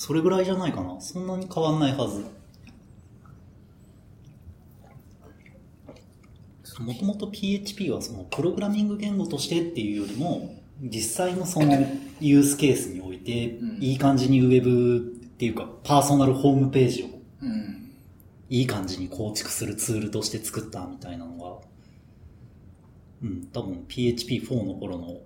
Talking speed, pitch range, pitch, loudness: 295 characters per minute, 105-140 Hz, 120 Hz, -25 LUFS